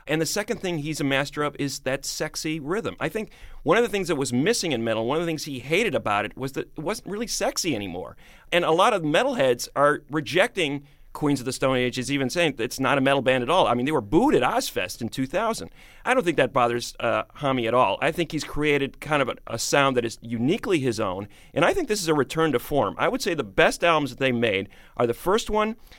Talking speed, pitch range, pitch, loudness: 260 wpm, 125-160 Hz, 140 Hz, -24 LUFS